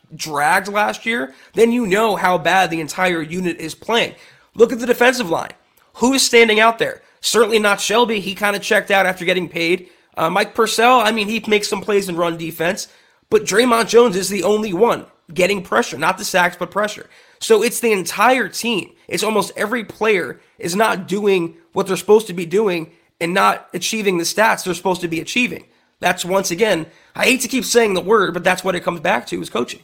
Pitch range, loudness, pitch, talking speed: 180-225 Hz, -17 LUFS, 200 Hz, 215 wpm